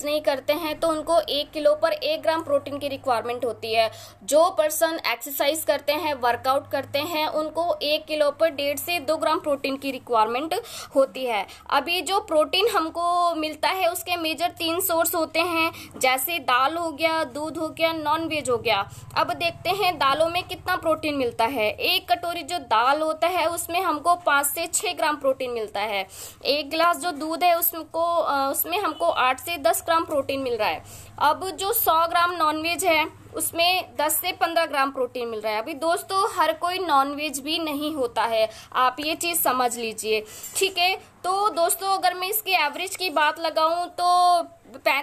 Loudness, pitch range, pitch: -23 LUFS, 280-340 Hz, 315 Hz